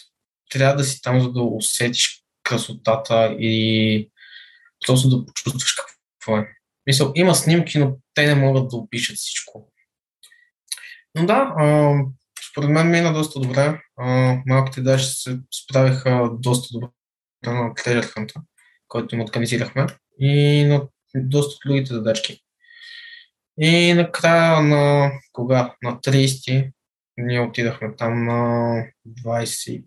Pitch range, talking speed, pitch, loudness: 120-145 Hz, 115 wpm, 130 Hz, -19 LUFS